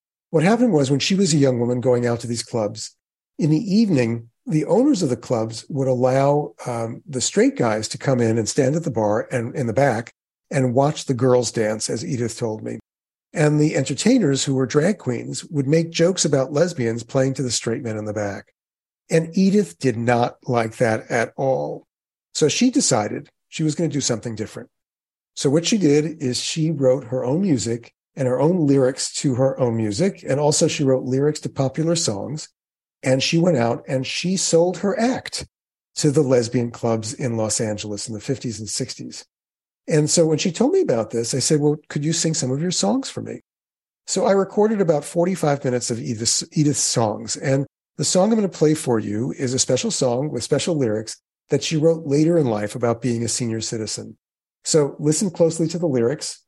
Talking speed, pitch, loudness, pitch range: 210 wpm, 135 Hz, -20 LUFS, 120-160 Hz